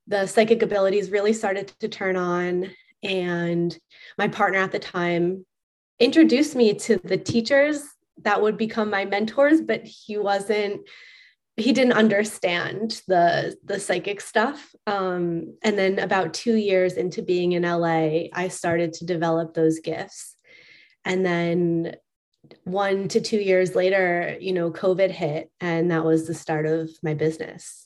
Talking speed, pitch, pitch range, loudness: 145 wpm, 190 Hz, 170-215 Hz, -23 LUFS